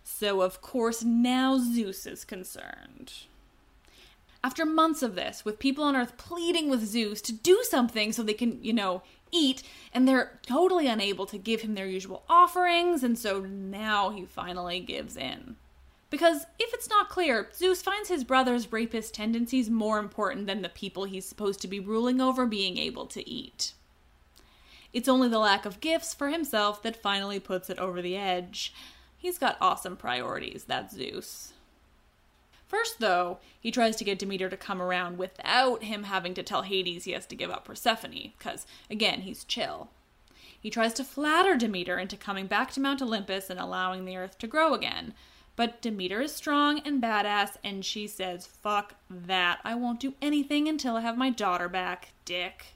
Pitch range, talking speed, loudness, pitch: 195-260 Hz, 180 wpm, -29 LUFS, 225 Hz